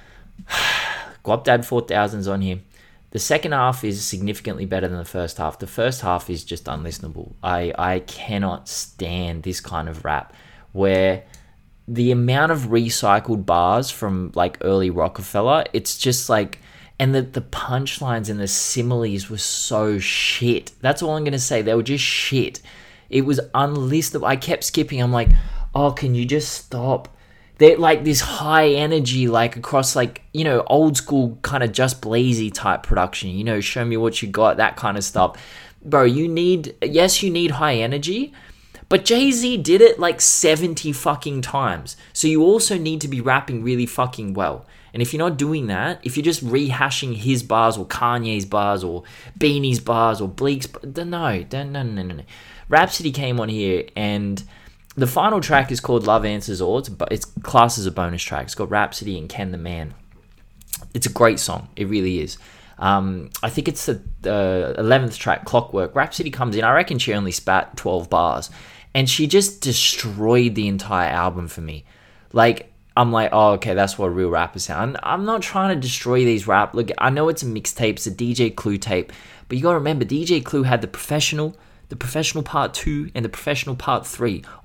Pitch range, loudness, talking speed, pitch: 100-140 Hz, -20 LUFS, 190 wpm, 120 Hz